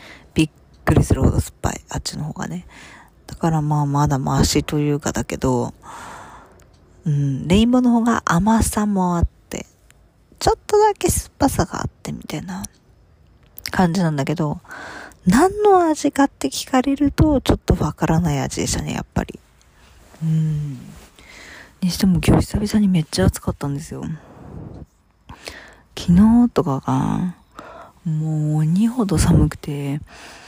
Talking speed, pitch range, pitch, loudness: 275 characters per minute, 145-225 Hz, 170 Hz, -19 LUFS